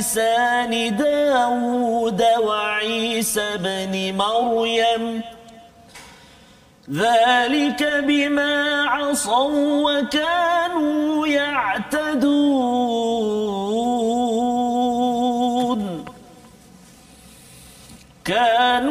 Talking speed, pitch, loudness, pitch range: 35 wpm, 245 Hz, -19 LUFS, 225-285 Hz